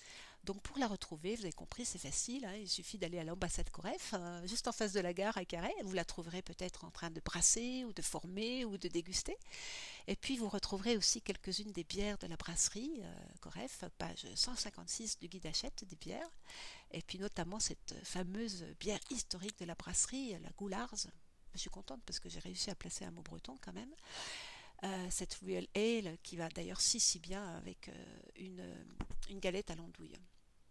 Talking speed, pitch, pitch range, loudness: 200 wpm, 195 Hz, 175-225 Hz, -41 LUFS